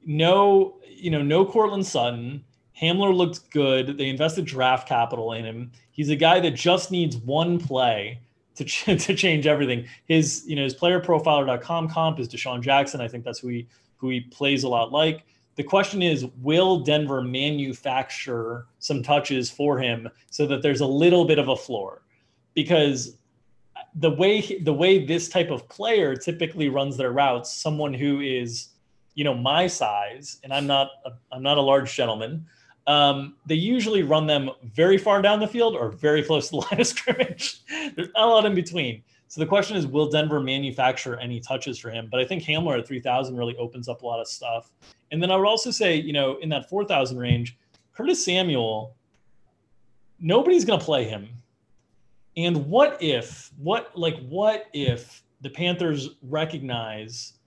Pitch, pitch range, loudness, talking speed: 145 Hz, 125-170 Hz, -23 LUFS, 180 wpm